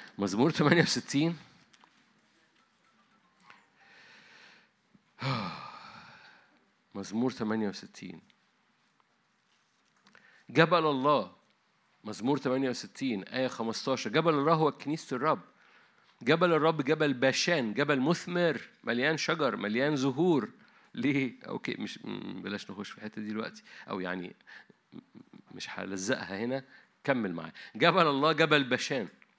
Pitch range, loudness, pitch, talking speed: 120-155 Hz, -30 LUFS, 140 Hz, 90 wpm